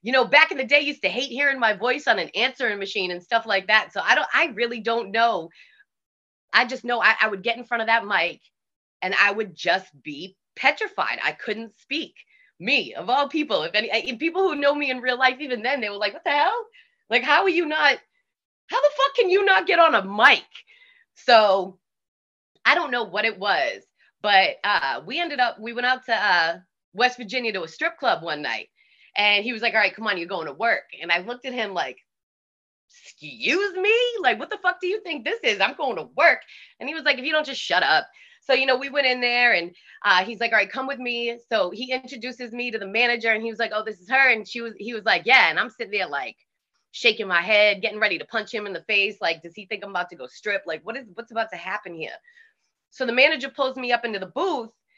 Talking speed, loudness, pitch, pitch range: 255 wpm, -22 LUFS, 240 Hz, 215-290 Hz